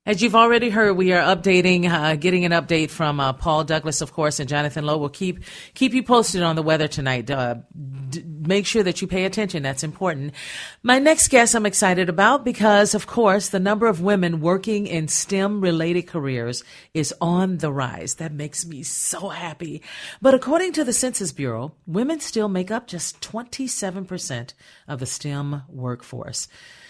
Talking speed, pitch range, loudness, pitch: 185 wpm, 150-210 Hz, -20 LUFS, 175 Hz